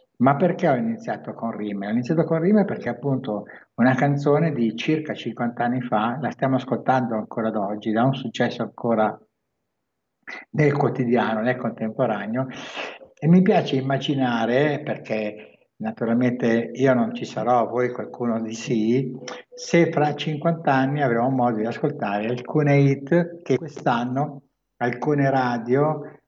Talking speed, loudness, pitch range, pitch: 140 wpm, -23 LUFS, 115-145 Hz, 130 Hz